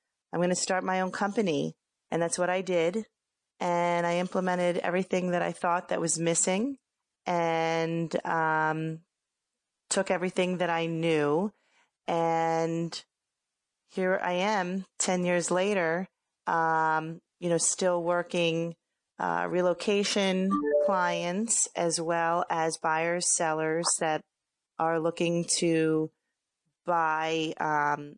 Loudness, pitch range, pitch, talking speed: -28 LUFS, 165-180 Hz, 170 Hz, 115 wpm